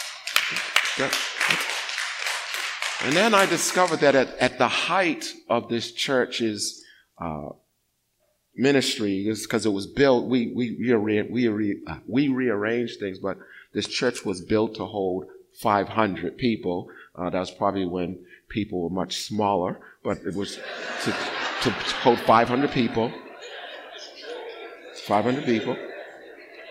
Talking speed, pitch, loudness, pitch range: 125 wpm, 110 Hz, -24 LUFS, 100-125 Hz